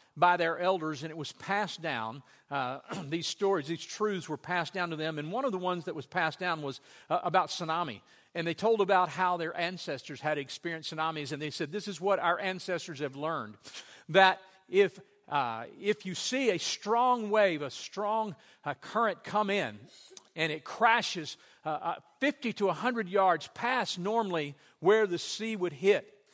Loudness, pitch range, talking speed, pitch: -31 LUFS, 160-205 Hz, 185 wpm, 180 Hz